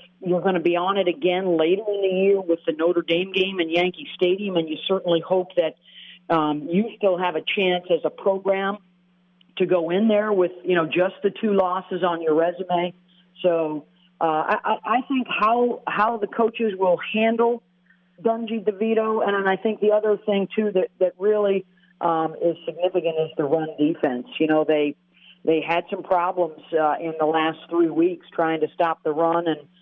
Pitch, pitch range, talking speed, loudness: 180 Hz, 165-200 Hz, 195 wpm, -22 LUFS